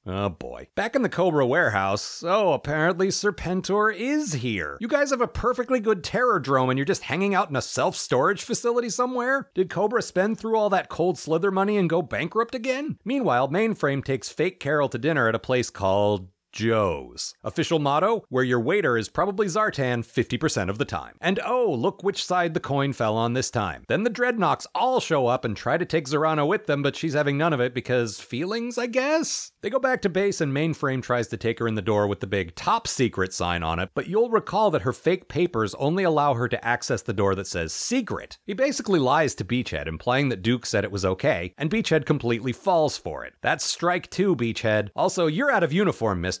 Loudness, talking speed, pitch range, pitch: -24 LUFS, 220 wpm, 120-200 Hz, 155 Hz